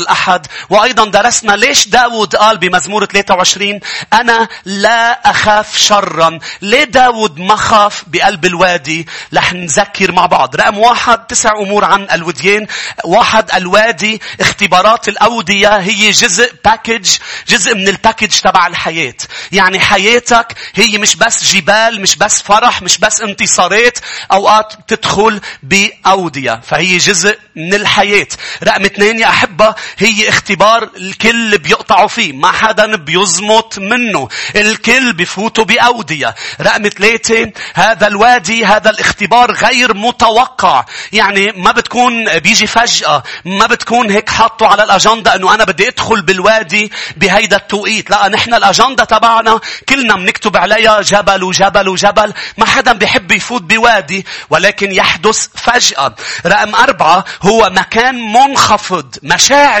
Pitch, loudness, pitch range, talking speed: 210 Hz, -9 LUFS, 195-225 Hz, 125 wpm